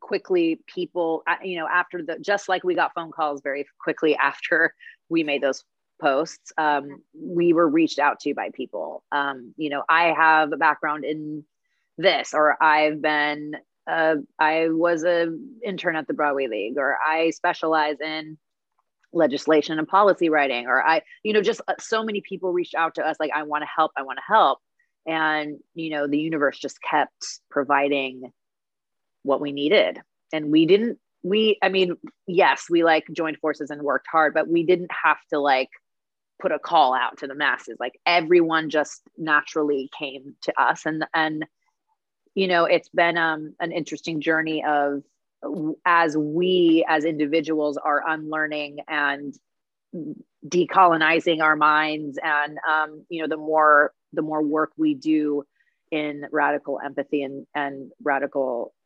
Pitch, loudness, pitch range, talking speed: 155 Hz, -22 LUFS, 150-170 Hz, 165 wpm